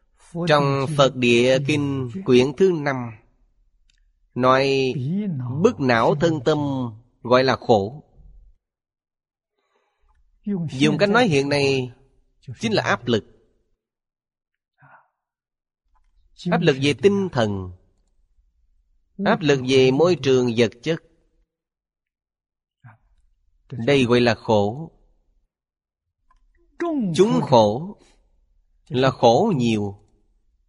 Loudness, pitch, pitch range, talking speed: -20 LUFS, 130 Hz, 100-150 Hz, 90 wpm